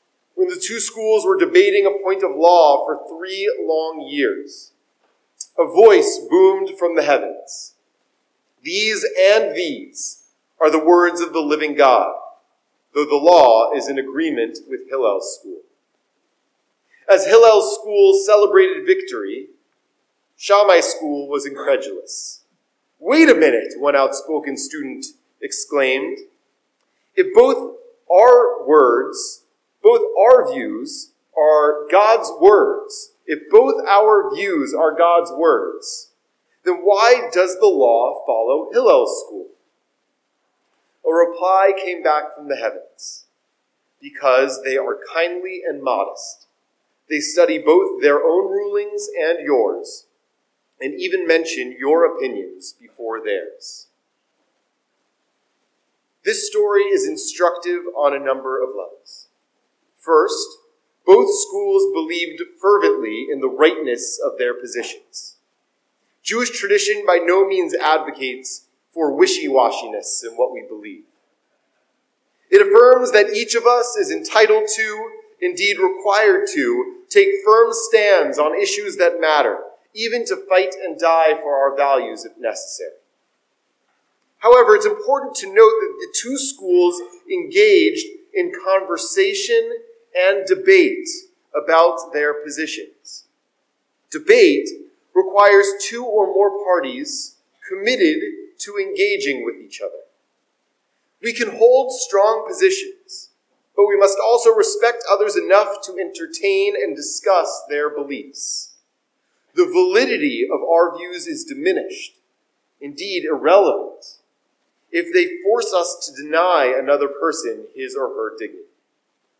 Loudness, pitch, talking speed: -16 LUFS, 360 Hz, 120 wpm